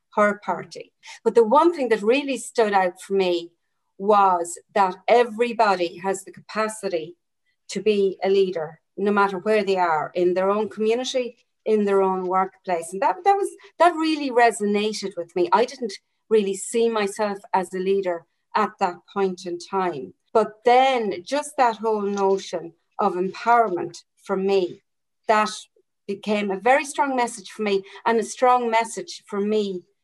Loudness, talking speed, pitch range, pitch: -22 LUFS, 160 wpm, 190-230 Hz, 205 Hz